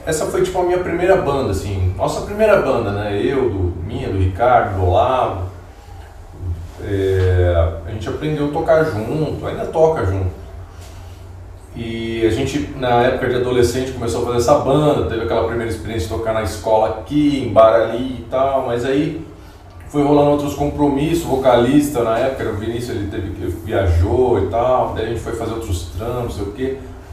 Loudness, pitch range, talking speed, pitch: -18 LUFS, 95-135 Hz, 185 wpm, 115 Hz